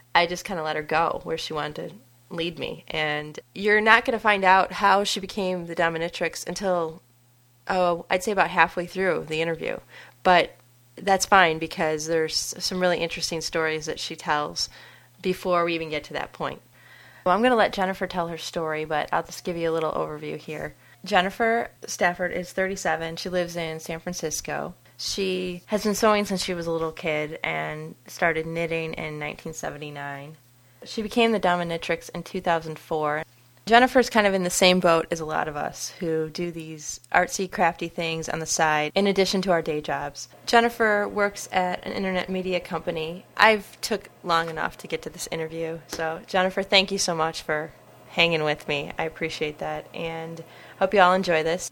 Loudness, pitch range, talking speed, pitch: -24 LUFS, 160-190 Hz, 190 wpm, 170 Hz